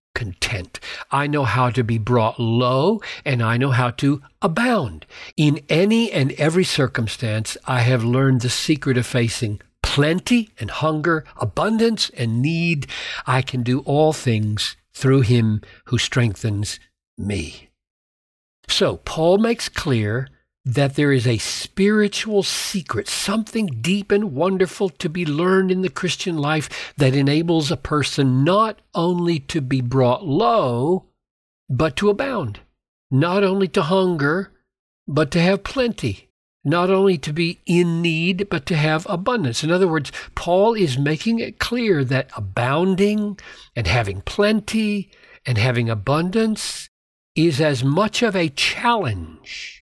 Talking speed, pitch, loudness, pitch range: 140 wpm, 155 Hz, -20 LUFS, 130-190 Hz